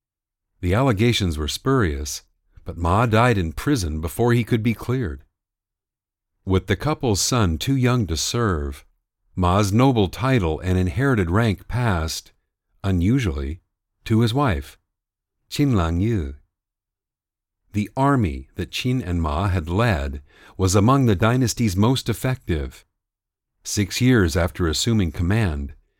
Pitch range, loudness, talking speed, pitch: 85-115 Hz, -21 LUFS, 125 wpm, 100 Hz